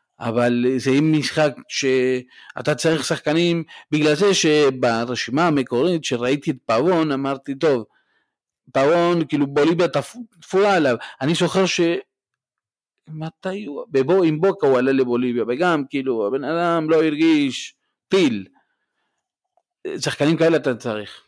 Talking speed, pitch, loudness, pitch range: 120 wpm, 155 Hz, -20 LUFS, 135-170 Hz